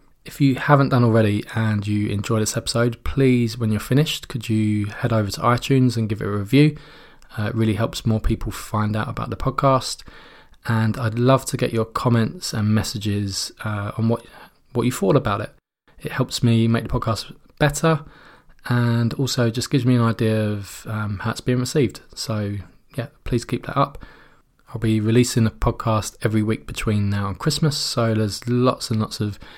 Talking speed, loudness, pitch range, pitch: 195 wpm, -21 LUFS, 110-125 Hz, 115 Hz